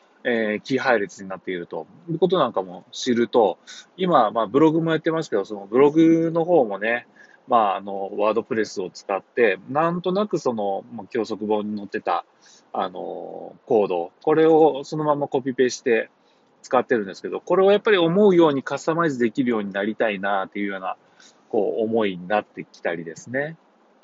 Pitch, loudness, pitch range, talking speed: 130 Hz, -22 LUFS, 105-165 Hz, 380 characters per minute